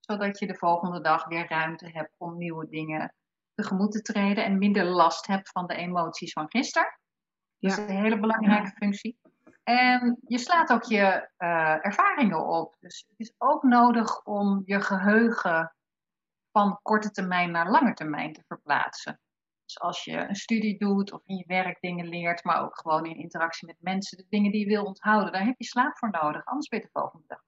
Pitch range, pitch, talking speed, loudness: 170-220 Hz, 200 Hz, 195 wpm, -26 LUFS